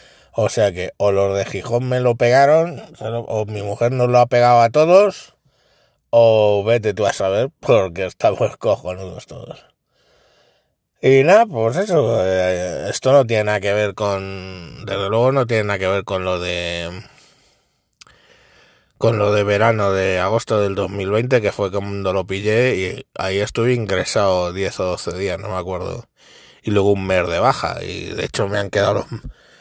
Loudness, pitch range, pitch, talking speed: -18 LUFS, 95-115 Hz, 105 Hz, 175 wpm